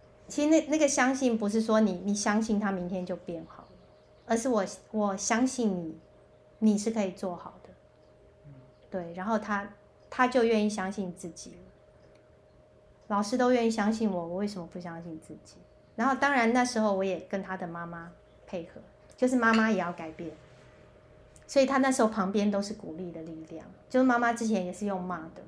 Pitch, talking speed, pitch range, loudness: 205 Hz, 265 characters per minute, 180-230 Hz, -29 LUFS